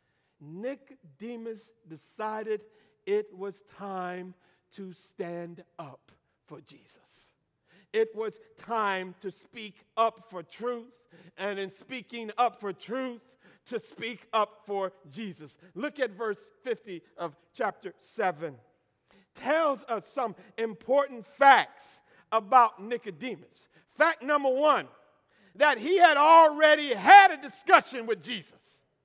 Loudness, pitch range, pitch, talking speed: -26 LUFS, 185-260 Hz, 220 Hz, 115 wpm